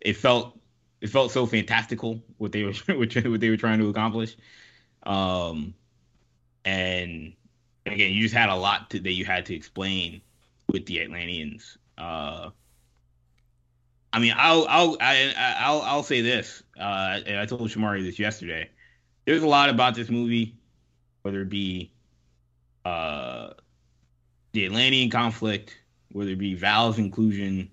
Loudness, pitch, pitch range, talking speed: -24 LUFS, 105 Hz, 90-115 Hz, 145 wpm